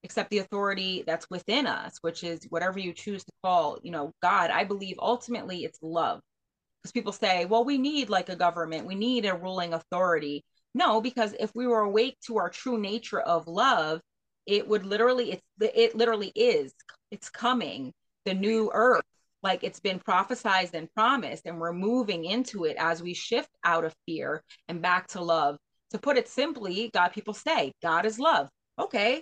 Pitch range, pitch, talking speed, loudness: 170-230 Hz, 200 Hz, 185 wpm, -28 LUFS